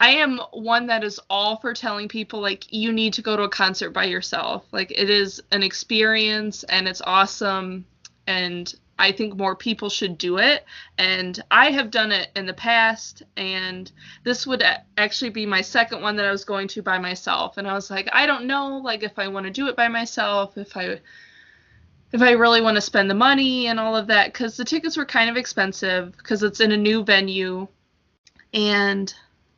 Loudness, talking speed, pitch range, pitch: -20 LUFS, 205 wpm, 195-230 Hz, 210 Hz